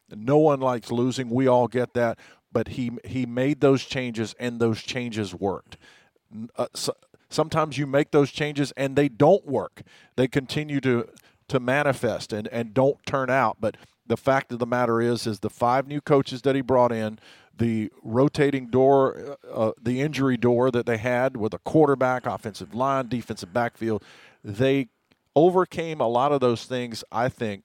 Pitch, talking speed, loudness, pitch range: 125 Hz, 180 wpm, -24 LUFS, 115-135 Hz